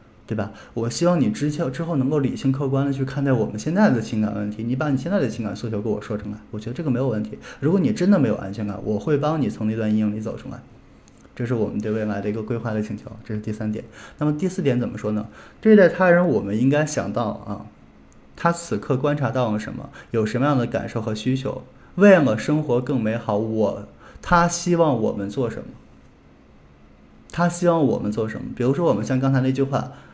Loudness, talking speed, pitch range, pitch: -22 LUFS, 340 characters per minute, 105-145 Hz, 115 Hz